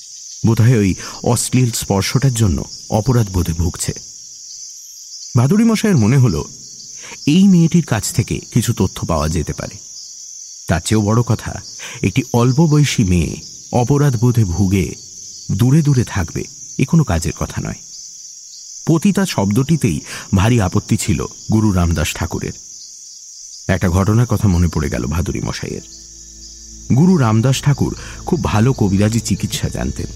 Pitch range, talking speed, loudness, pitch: 90-125 Hz, 125 wpm, -16 LUFS, 110 Hz